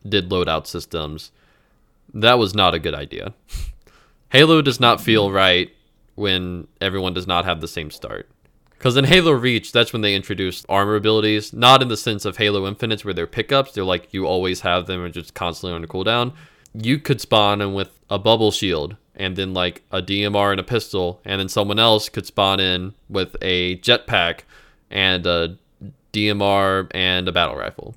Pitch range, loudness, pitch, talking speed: 90-110 Hz, -18 LUFS, 100 Hz, 185 wpm